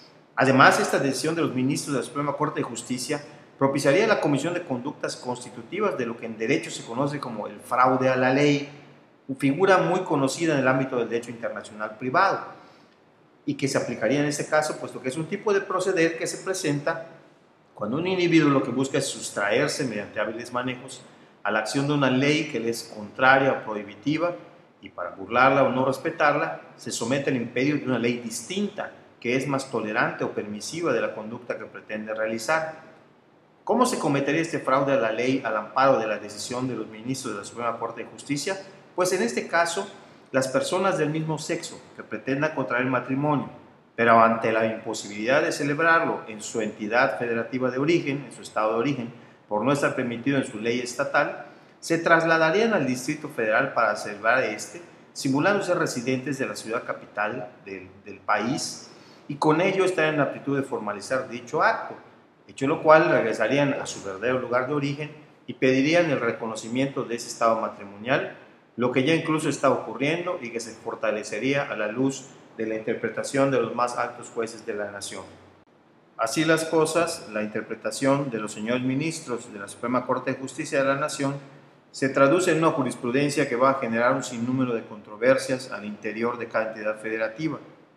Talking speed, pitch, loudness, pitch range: 190 wpm, 135 Hz, -25 LUFS, 115-150 Hz